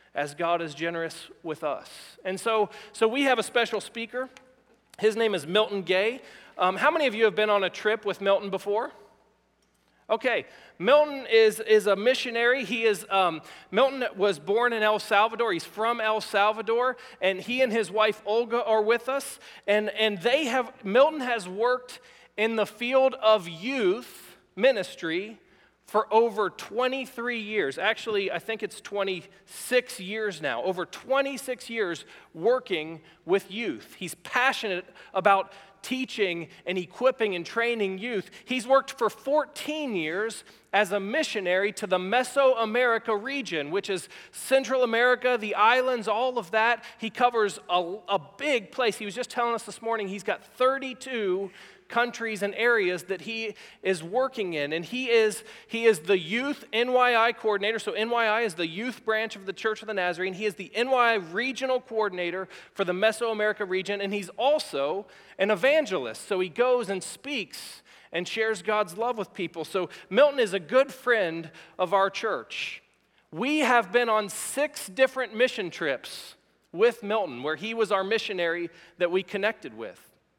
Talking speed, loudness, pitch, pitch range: 165 wpm, -26 LUFS, 220 Hz, 195-245 Hz